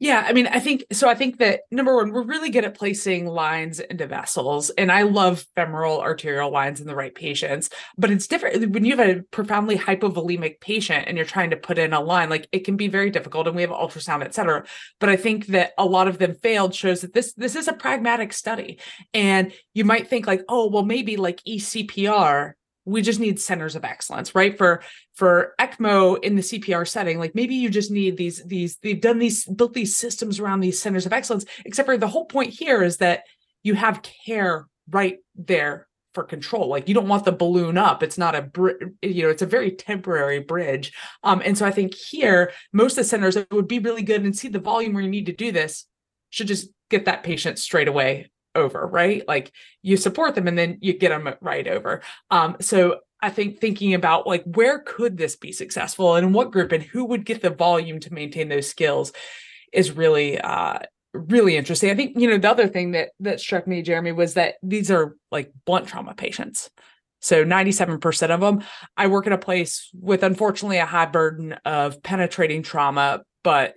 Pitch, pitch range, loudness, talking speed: 190 Hz, 170-215 Hz, -21 LUFS, 215 wpm